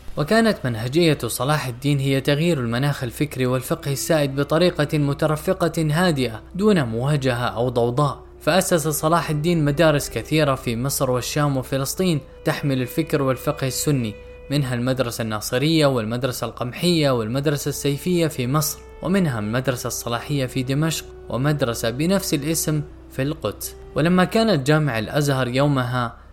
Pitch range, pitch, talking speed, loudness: 125-155 Hz, 140 Hz, 125 wpm, -21 LUFS